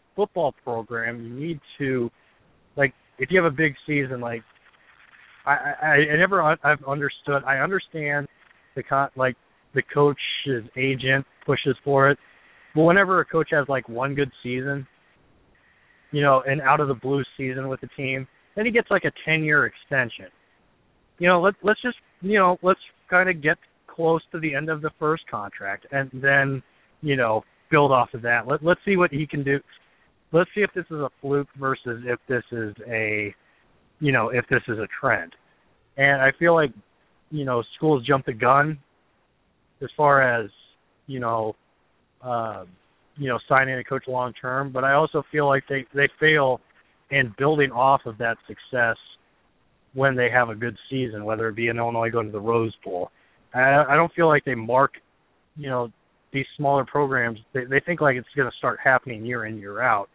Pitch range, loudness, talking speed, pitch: 125-150 Hz, -23 LUFS, 190 wpm, 135 Hz